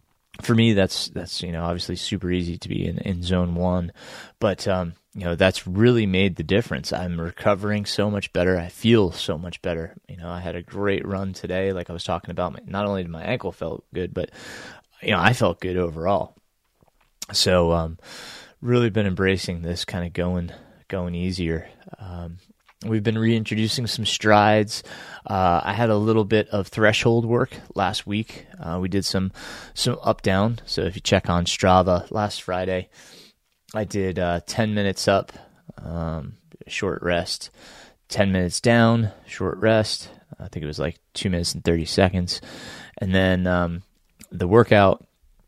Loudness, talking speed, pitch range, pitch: -23 LUFS, 175 wpm, 90-105 Hz, 95 Hz